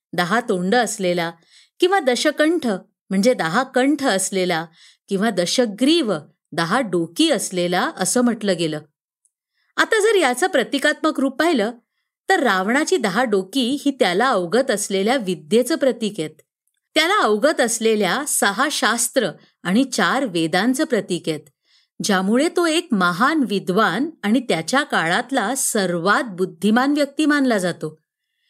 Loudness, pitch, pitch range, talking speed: -19 LUFS, 235 Hz, 185-275 Hz, 120 wpm